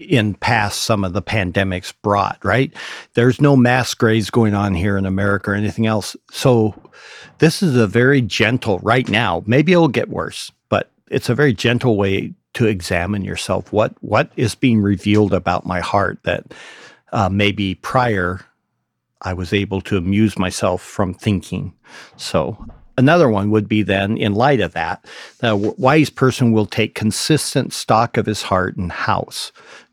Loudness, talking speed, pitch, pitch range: -17 LUFS, 170 wpm, 105 Hz, 100-120 Hz